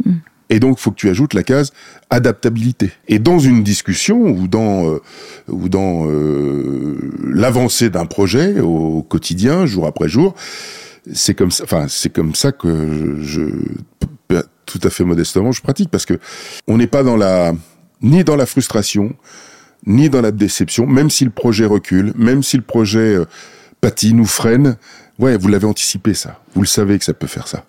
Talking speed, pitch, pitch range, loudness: 180 wpm, 110 Hz, 95-130 Hz, -14 LUFS